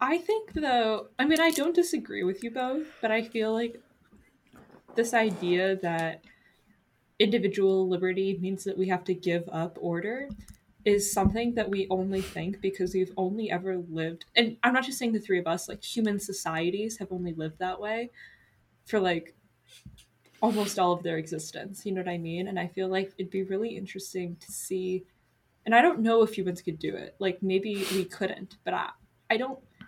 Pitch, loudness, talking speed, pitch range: 195 Hz, -29 LUFS, 190 wpm, 185-225 Hz